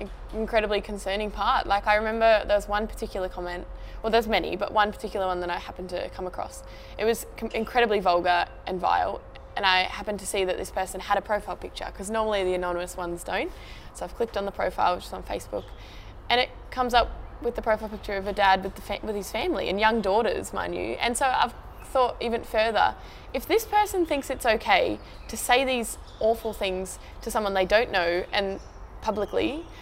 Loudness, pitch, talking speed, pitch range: -26 LUFS, 210 Hz, 210 wpm, 190-225 Hz